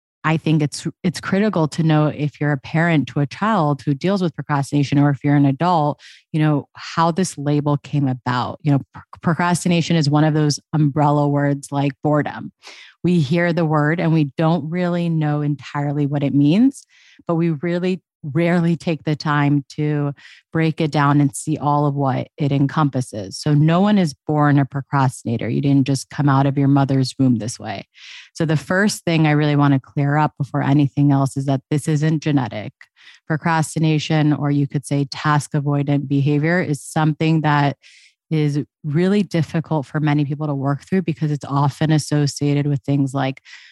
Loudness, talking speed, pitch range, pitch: -19 LUFS, 185 wpm, 140-160 Hz, 150 Hz